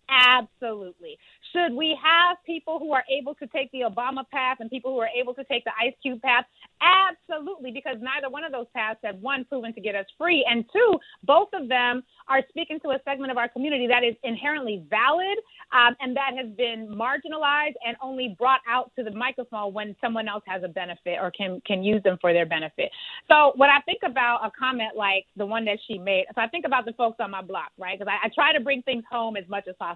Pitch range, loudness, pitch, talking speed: 220-285 Hz, -24 LUFS, 250 Hz, 235 wpm